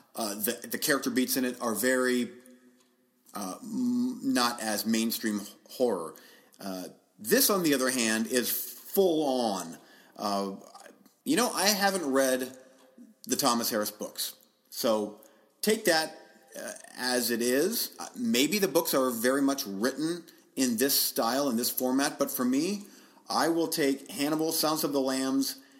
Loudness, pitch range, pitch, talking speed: -28 LUFS, 120-165 Hz, 130 Hz, 155 wpm